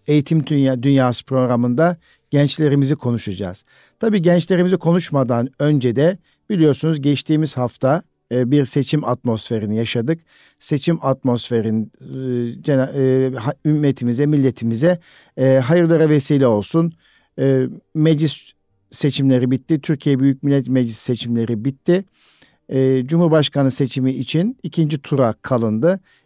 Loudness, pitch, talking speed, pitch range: -18 LUFS, 140 Hz, 90 wpm, 125-160 Hz